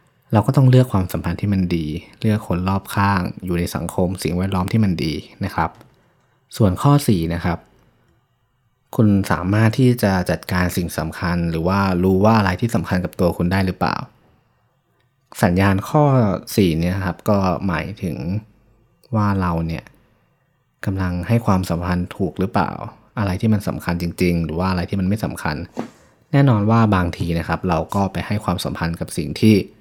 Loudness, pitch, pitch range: -19 LUFS, 95 Hz, 85-110 Hz